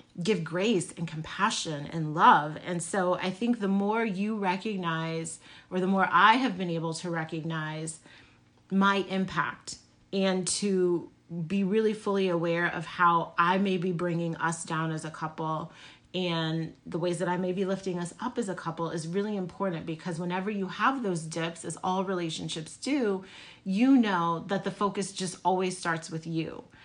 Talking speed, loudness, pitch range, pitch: 175 wpm, -29 LUFS, 165-195 Hz, 180 Hz